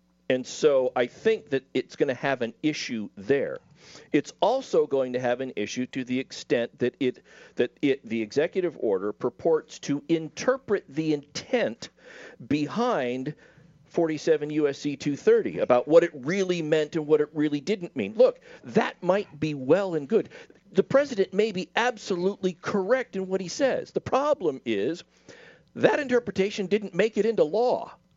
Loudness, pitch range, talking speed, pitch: -26 LUFS, 145-220 Hz, 160 wpm, 175 Hz